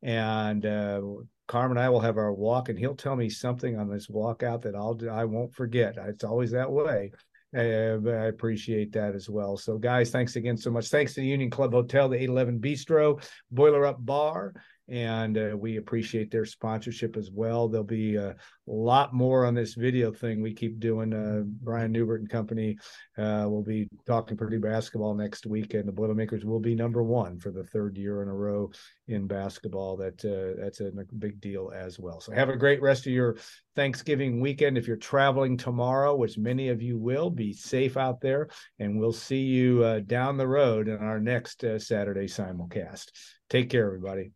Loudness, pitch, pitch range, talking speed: -28 LUFS, 115 Hz, 105-125 Hz, 200 wpm